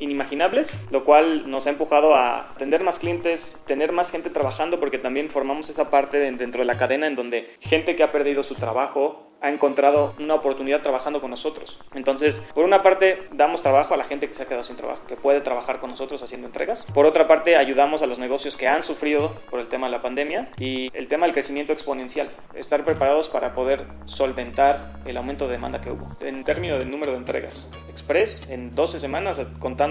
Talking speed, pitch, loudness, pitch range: 210 wpm, 140 Hz, -22 LUFS, 130-155 Hz